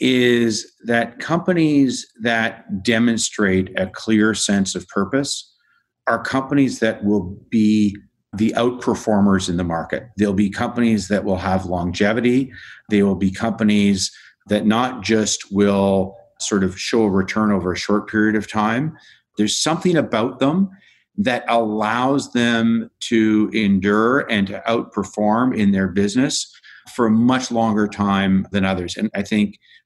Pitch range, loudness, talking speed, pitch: 100-115 Hz, -19 LUFS, 145 wpm, 105 Hz